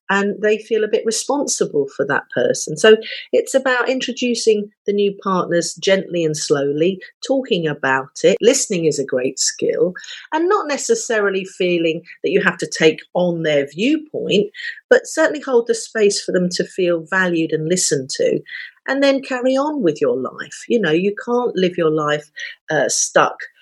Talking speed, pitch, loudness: 175 wpm, 220 Hz, -18 LUFS